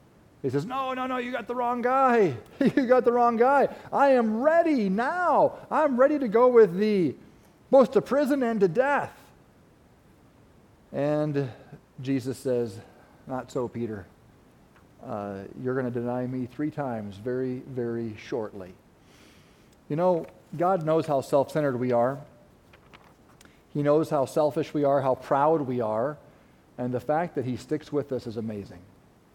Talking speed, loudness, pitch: 155 wpm, -26 LUFS, 145 Hz